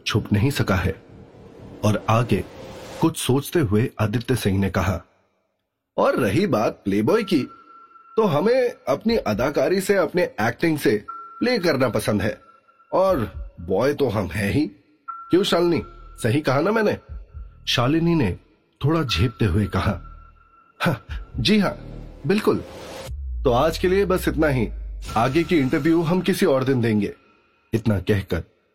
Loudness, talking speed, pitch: -22 LUFS, 145 wpm, 130 Hz